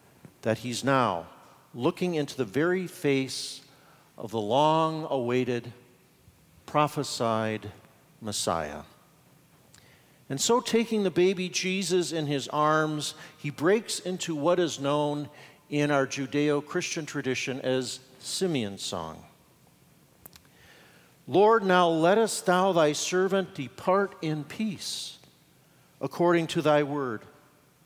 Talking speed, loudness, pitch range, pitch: 110 wpm, -27 LUFS, 130-175 Hz, 150 Hz